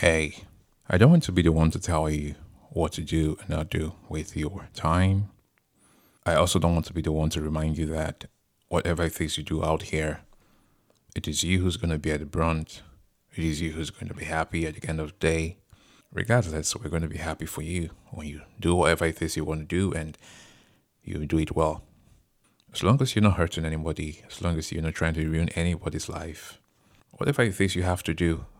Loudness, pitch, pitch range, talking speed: -27 LUFS, 80 Hz, 80-90 Hz, 230 wpm